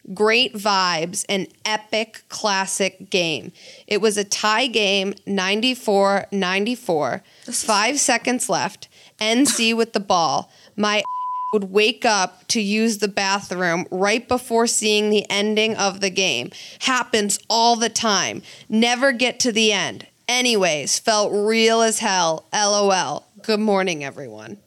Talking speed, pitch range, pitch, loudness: 135 wpm, 195-230 Hz, 210 Hz, -19 LUFS